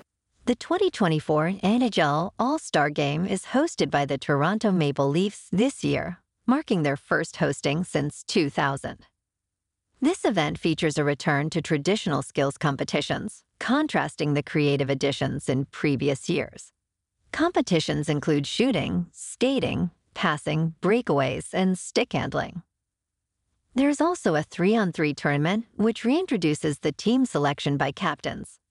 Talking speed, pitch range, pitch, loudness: 130 wpm, 145-215 Hz, 155 Hz, -25 LUFS